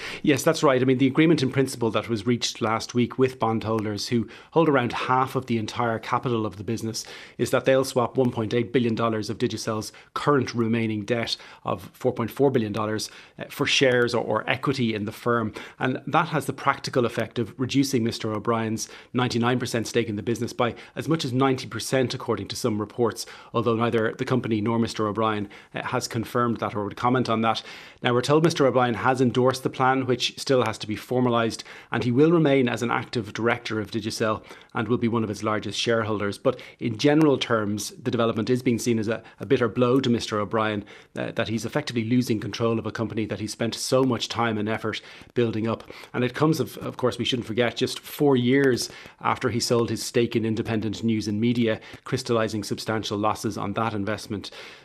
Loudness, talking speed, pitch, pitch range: -25 LUFS, 200 wpm, 115 Hz, 110-130 Hz